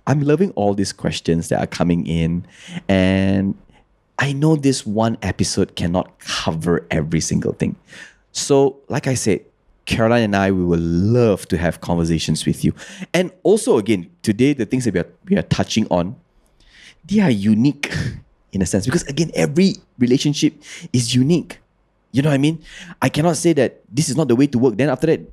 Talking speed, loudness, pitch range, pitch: 185 wpm, -18 LUFS, 95-150 Hz, 125 Hz